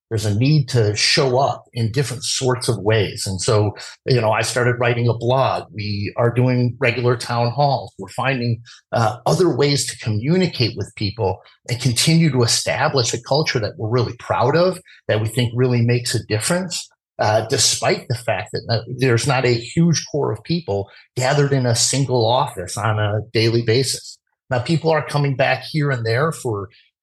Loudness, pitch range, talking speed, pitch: -19 LUFS, 110-135 Hz, 185 wpm, 120 Hz